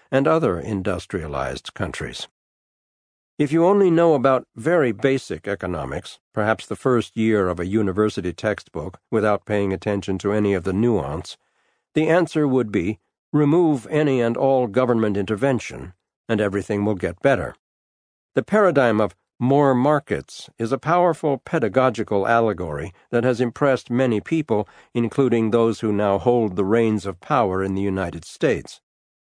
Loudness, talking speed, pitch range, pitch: -21 LUFS, 145 wpm, 100-135 Hz, 110 Hz